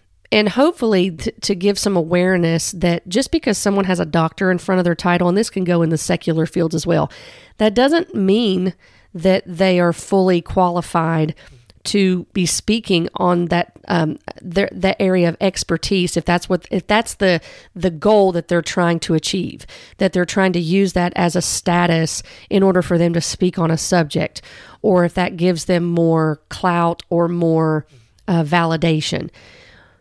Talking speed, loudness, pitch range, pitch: 180 wpm, -17 LUFS, 170-190 Hz, 180 Hz